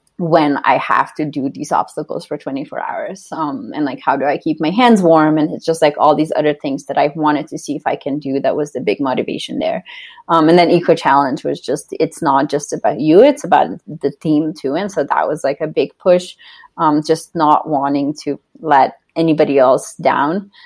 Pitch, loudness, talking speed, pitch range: 155 Hz, -15 LUFS, 225 wpm, 145-180 Hz